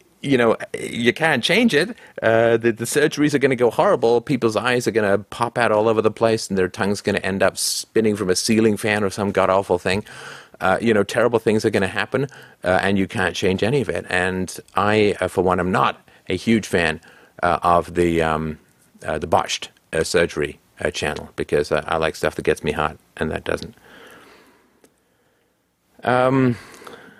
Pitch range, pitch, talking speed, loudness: 95-120 Hz, 105 Hz, 205 wpm, -20 LUFS